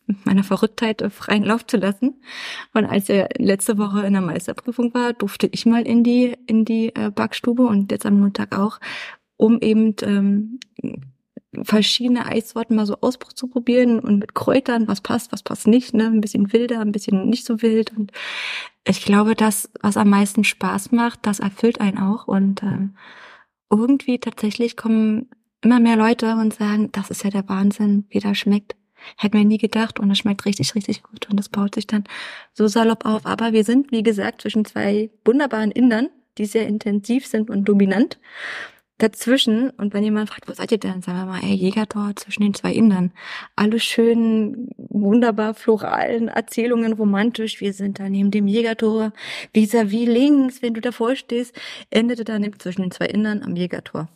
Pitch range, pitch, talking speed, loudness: 205-235 Hz, 220 Hz, 180 wpm, -19 LUFS